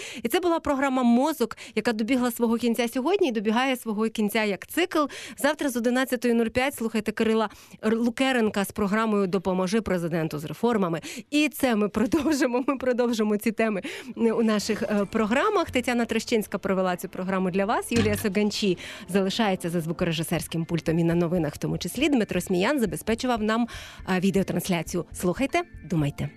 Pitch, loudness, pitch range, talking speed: 220 Hz, -25 LUFS, 190-250 Hz, 150 wpm